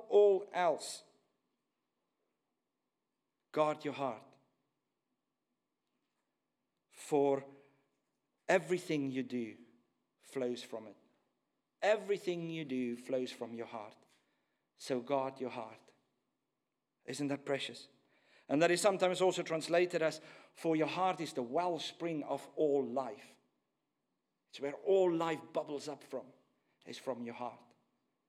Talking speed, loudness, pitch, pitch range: 110 wpm, -36 LUFS, 145 Hz, 130-170 Hz